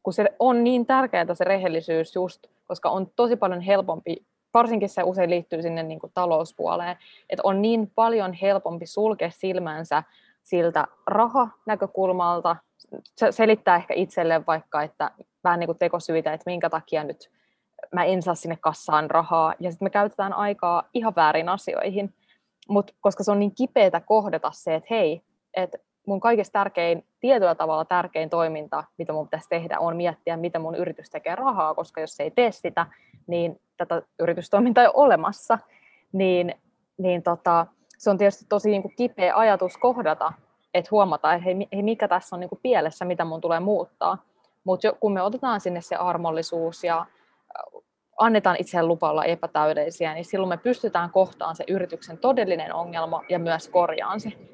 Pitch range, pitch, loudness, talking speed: 165-205 Hz, 180 Hz, -24 LUFS, 165 wpm